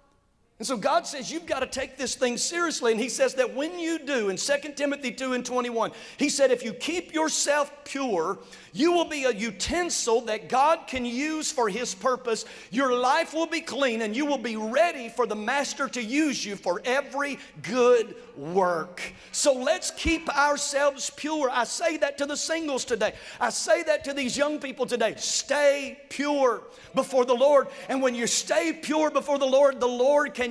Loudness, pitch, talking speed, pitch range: -26 LUFS, 270 Hz, 195 wpm, 245-290 Hz